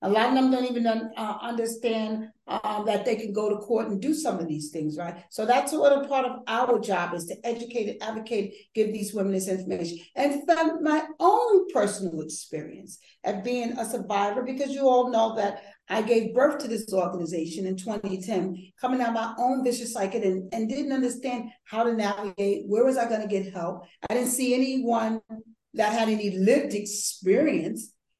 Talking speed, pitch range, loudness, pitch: 195 wpm, 200-245 Hz, -26 LUFS, 225 Hz